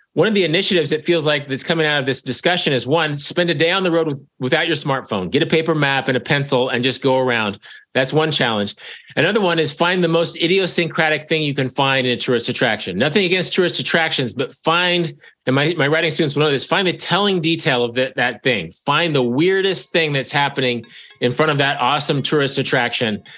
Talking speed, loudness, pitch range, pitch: 230 wpm, -17 LUFS, 135-170 Hz, 150 Hz